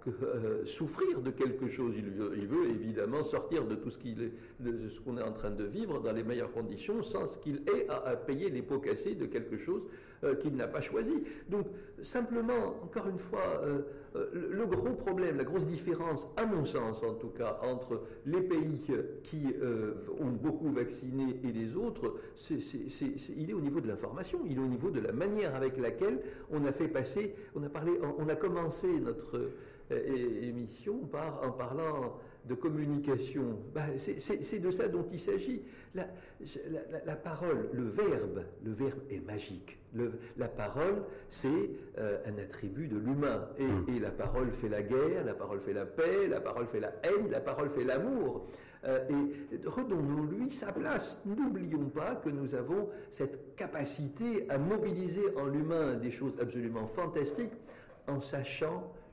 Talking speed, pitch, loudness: 185 wpm, 150 Hz, -36 LUFS